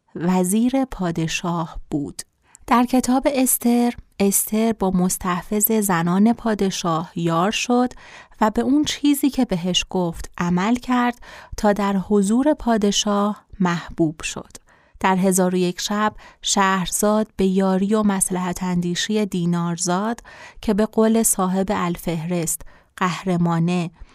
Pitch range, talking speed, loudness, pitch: 180-225 Hz, 115 wpm, -20 LUFS, 195 Hz